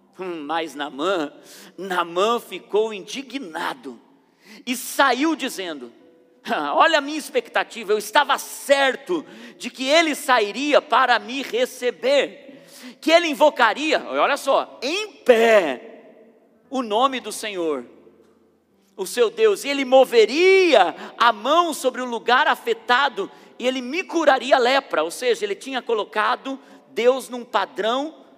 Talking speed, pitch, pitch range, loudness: 125 wpm, 260 Hz, 225-305 Hz, -20 LUFS